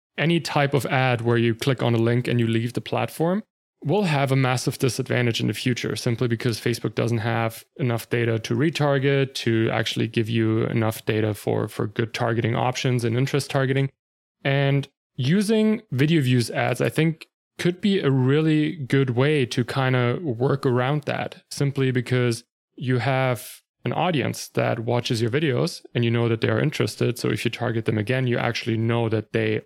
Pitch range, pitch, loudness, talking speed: 115-140 Hz, 125 Hz, -23 LUFS, 190 wpm